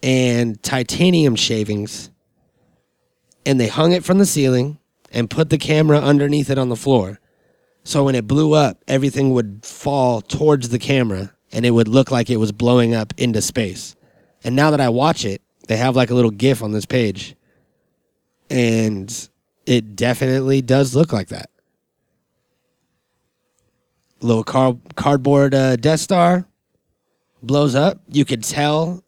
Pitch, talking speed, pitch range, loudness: 130 Hz, 155 wpm, 115-145 Hz, -17 LUFS